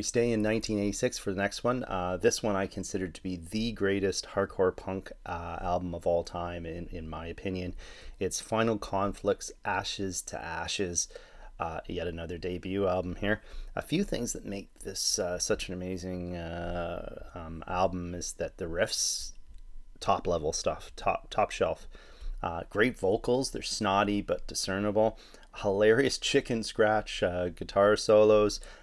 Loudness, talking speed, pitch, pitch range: -31 LUFS, 155 wpm, 95 Hz, 85-105 Hz